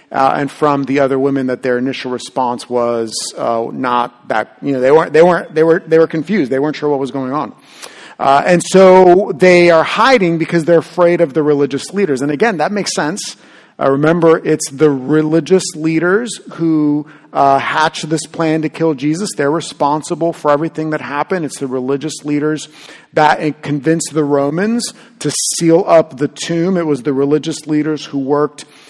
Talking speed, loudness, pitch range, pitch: 185 wpm, -14 LUFS, 140-165 Hz, 155 Hz